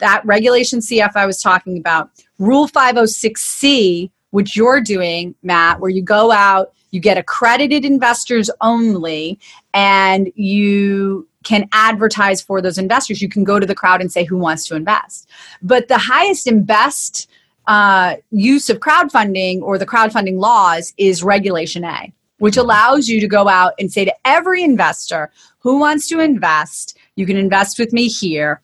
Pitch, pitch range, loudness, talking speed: 200 Hz, 190-235 Hz, -13 LUFS, 165 wpm